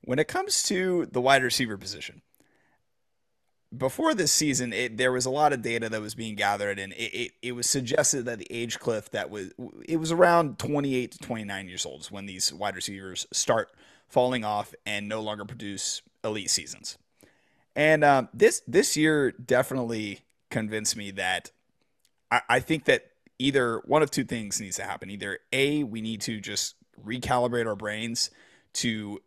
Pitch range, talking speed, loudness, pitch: 105-140 Hz, 180 wpm, -27 LUFS, 120 Hz